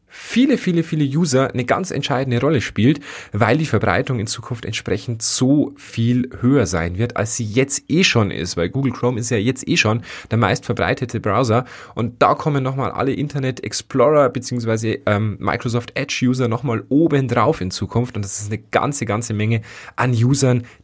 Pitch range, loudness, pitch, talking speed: 110-135 Hz, -19 LUFS, 120 Hz, 185 wpm